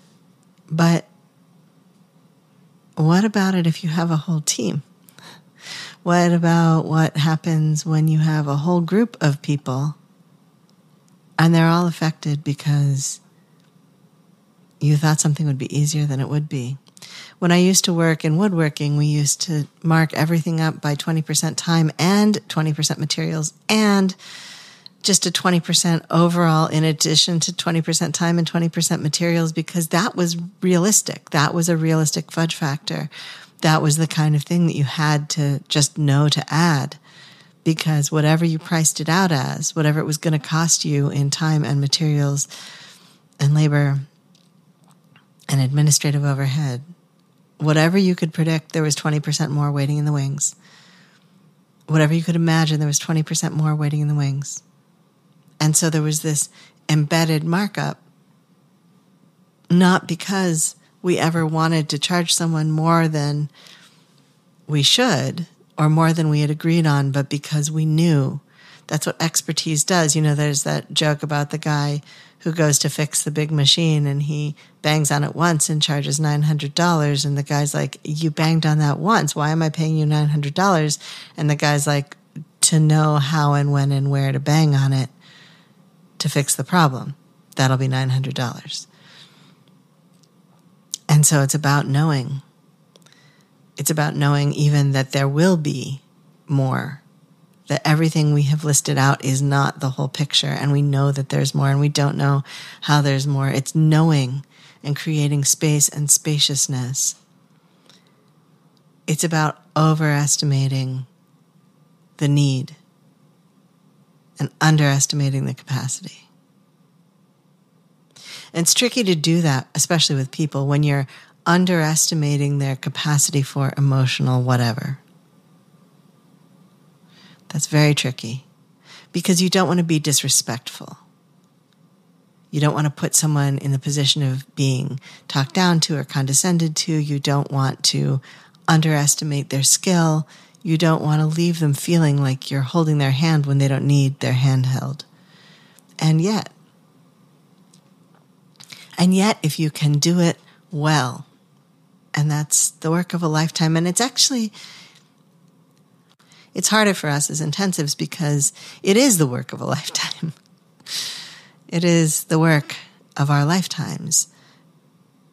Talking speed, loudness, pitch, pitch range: 145 wpm, -19 LUFS, 160 Hz, 145-175 Hz